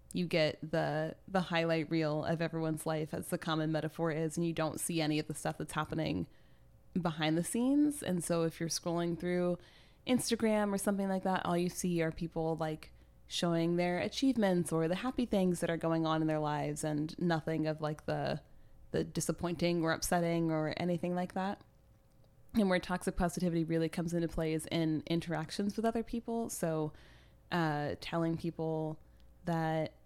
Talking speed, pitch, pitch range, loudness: 180 wpm, 165 Hz, 160-180 Hz, -35 LUFS